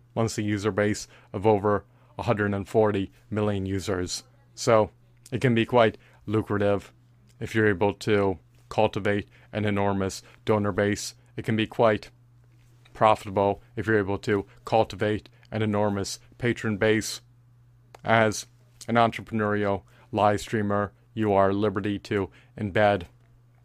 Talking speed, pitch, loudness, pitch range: 120 wpm, 110 Hz, -26 LUFS, 105-120 Hz